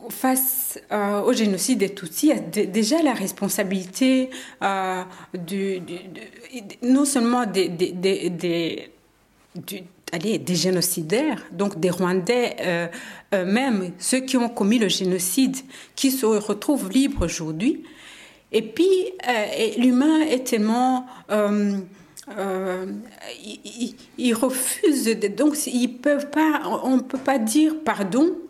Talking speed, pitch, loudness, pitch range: 130 wpm, 220 Hz, -22 LUFS, 190-260 Hz